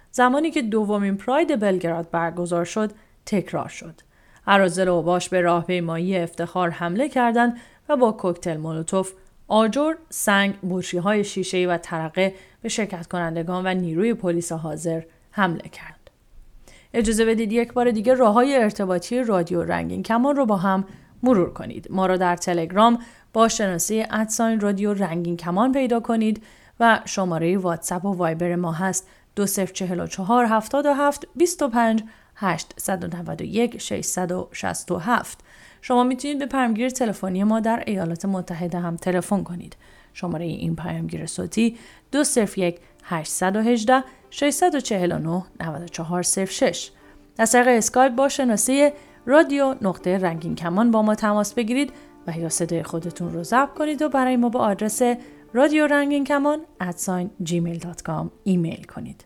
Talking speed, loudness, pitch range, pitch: 125 wpm, -22 LUFS, 175-240 Hz, 200 Hz